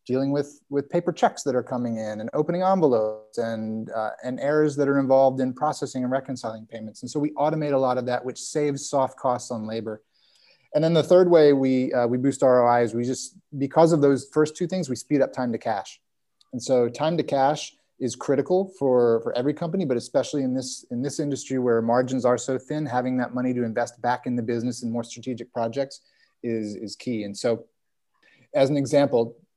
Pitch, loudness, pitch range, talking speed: 130 Hz, -24 LUFS, 120-145 Hz, 215 wpm